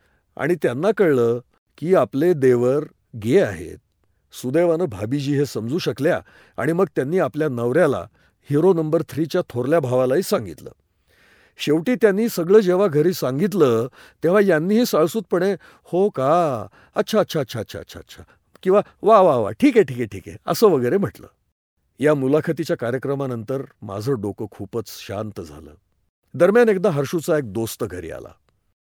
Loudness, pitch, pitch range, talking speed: -20 LUFS, 150 Hz, 120-180 Hz, 135 wpm